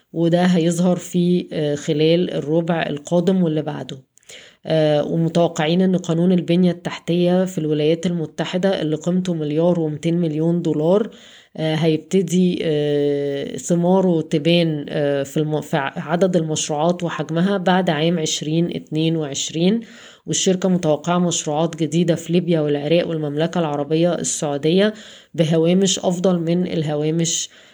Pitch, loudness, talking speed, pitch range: 165 Hz, -19 LUFS, 100 wpm, 155-175 Hz